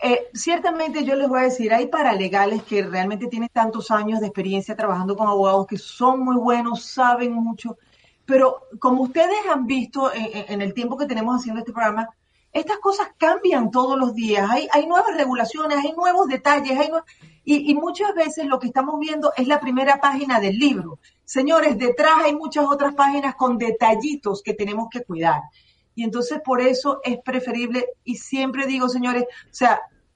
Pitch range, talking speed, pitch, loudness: 225-290 Hz, 185 wpm, 255 Hz, -20 LUFS